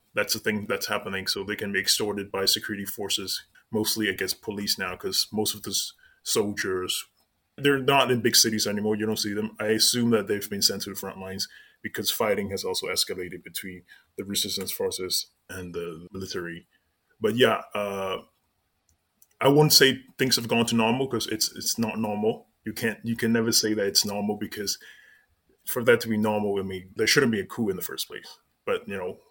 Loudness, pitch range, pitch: -25 LUFS, 95-115 Hz, 105 Hz